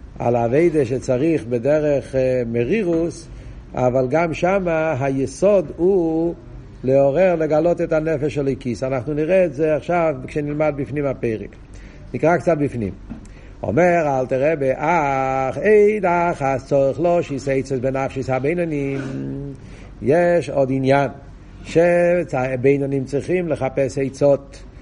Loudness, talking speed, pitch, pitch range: -19 LUFS, 120 wpm, 140 Hz, 130-165 Hz